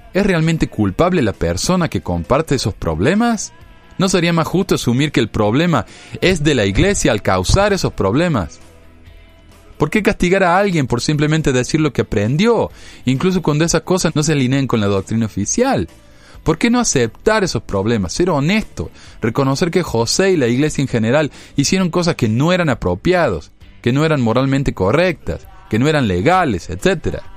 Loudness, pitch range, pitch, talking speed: -16 LUFS, 105-170 Hz, 135 Hz, 175 wpm